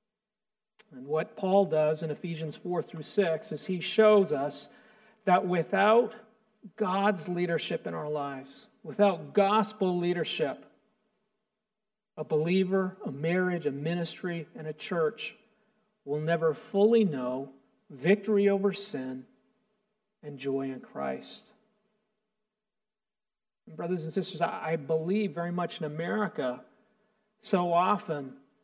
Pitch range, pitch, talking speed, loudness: 160-215 Hz, 195 Hz, 115 wpm, -29 LUFS